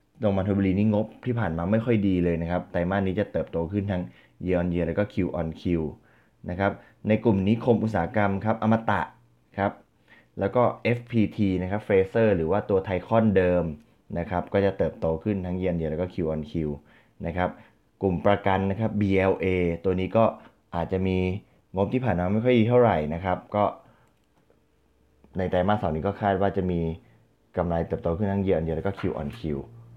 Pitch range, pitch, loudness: 85-105 Hz, 95 Hz, -26 LUFS